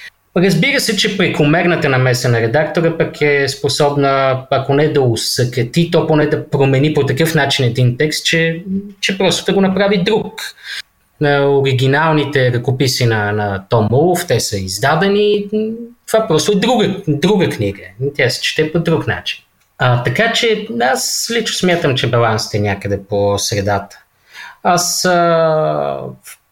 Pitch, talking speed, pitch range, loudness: 150 Hz, 145 wpm, 125-185 Hz, -14 LUFS